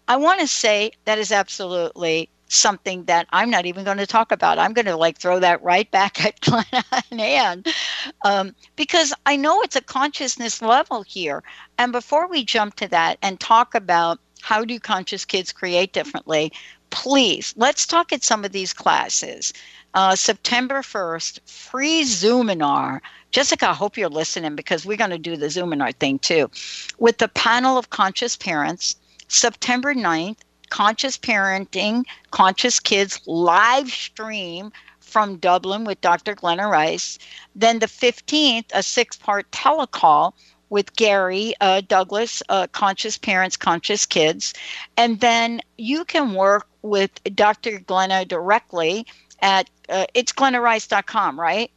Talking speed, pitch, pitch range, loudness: 150 wpm, 210 Hz, 190-245 Hz, -19 LUFS